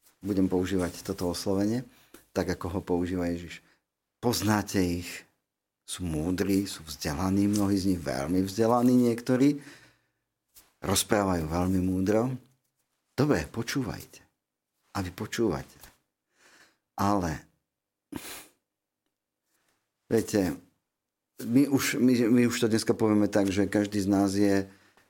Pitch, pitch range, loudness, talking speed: 100 Hz, 90-115 Hz, -28 LUFS, 110 wpm